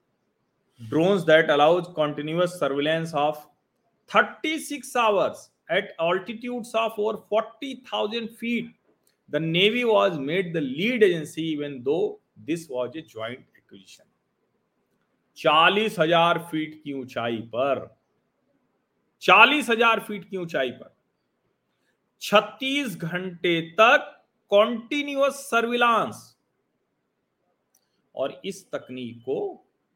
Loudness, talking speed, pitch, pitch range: -23 LUFS, 100 wpm, 190 Hz, 155-230 Hz